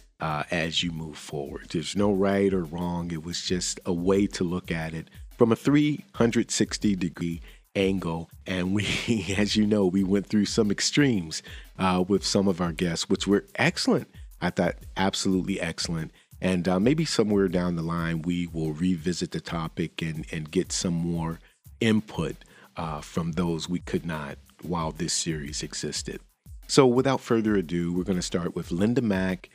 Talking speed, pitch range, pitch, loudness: 175 wpm, 85-100 Hz, 90 Hz, -26 LUFS